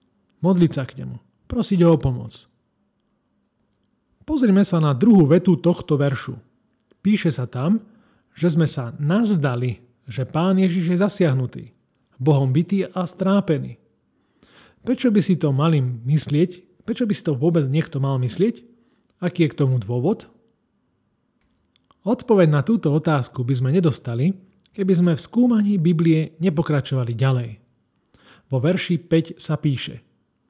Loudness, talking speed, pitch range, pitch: -20 LUFS, 135 wpm, 135-190 Hz, 165 Hz